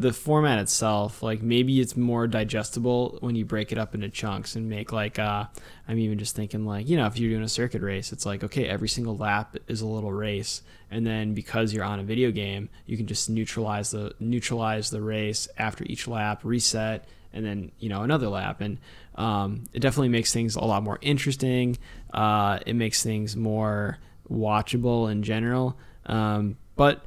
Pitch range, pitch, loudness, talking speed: 105-115 Hz, 110 Hz, -27 LUFS, 195 wpm